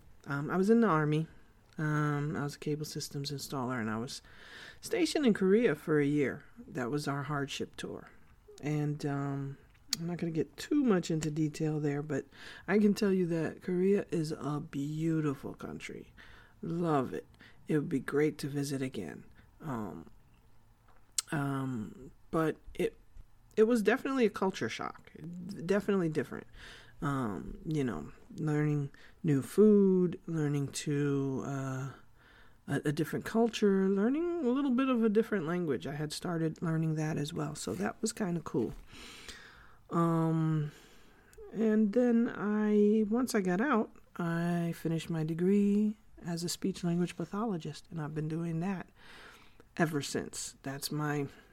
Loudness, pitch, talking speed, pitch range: -32 LUFS, 160 Hz, 155 wpm, 145-195 Hz